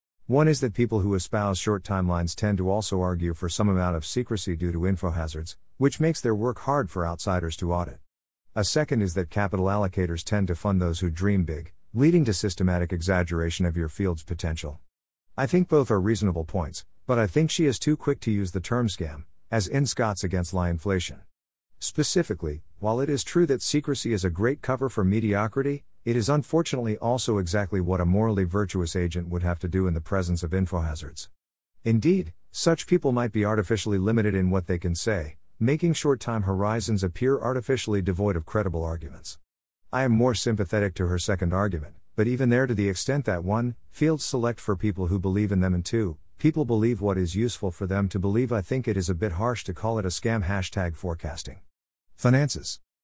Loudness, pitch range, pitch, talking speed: -26 LUFS, 90-115 Hz, 100 Hz, 200 wpm